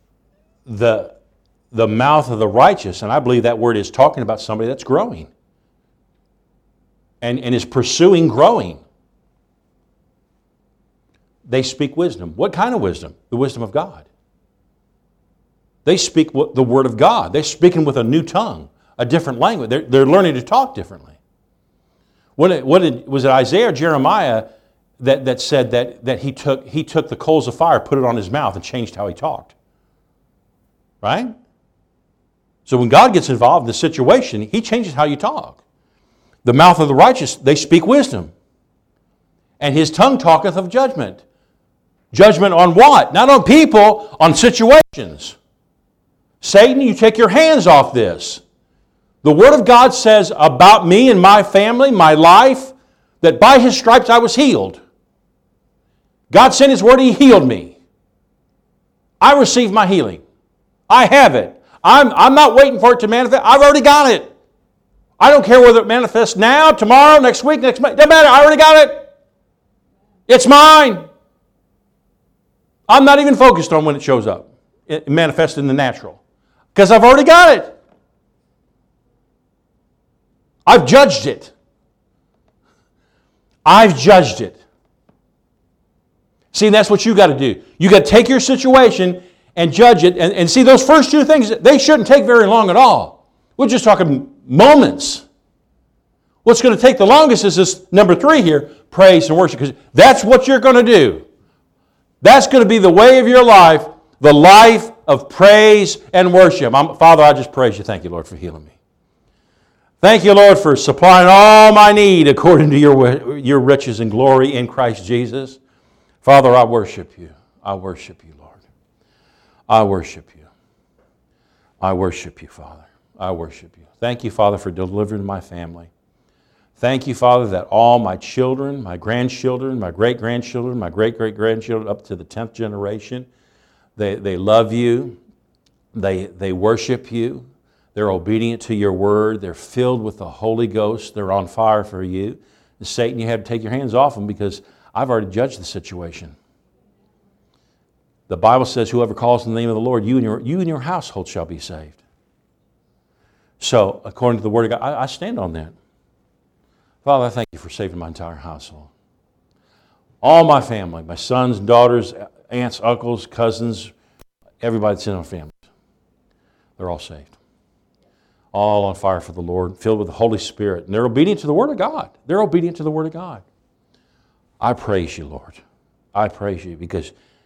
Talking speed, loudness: 170 wpm, -11 LUFS